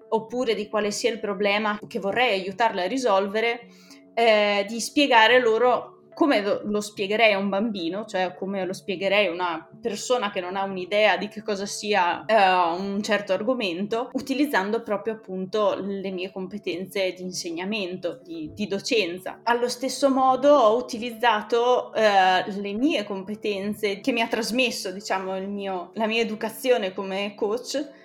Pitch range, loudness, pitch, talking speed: 195-235 Hz, -24 LUFS, 210 Hz, 155 wpm